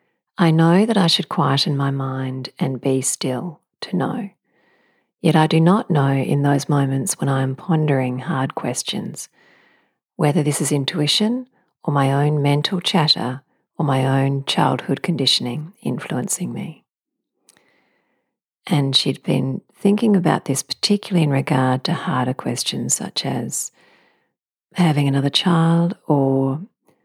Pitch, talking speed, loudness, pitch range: 145 Hz, 135 wpm, -19 LUFS, 135-170 Hz